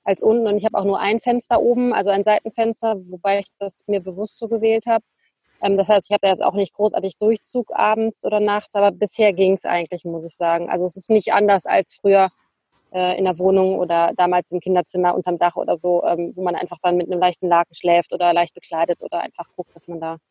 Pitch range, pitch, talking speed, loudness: 175-210 Hz, 190 Hz, 240 wpm, -19 LUFS